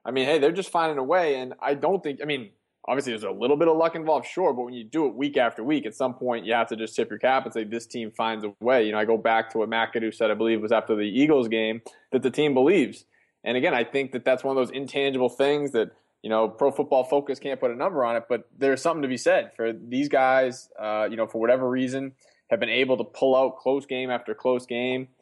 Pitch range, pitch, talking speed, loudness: 115-140 Hz, 130 Hz, 280 wpm, -25 LUFS